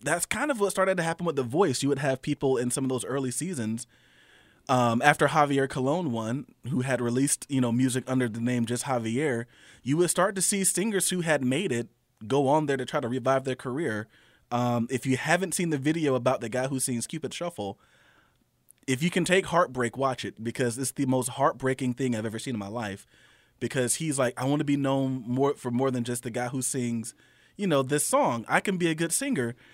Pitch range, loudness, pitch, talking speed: 125-150 Hz, -27 LUFS, 130 Hz, 230 wpm